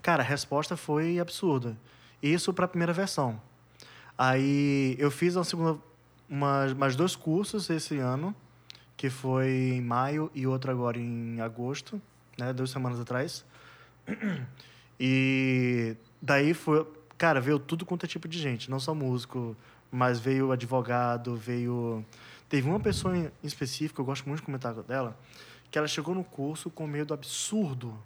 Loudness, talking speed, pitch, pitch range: -30 LUFS, 155 wpm, 135 Hz, 125-160 Hz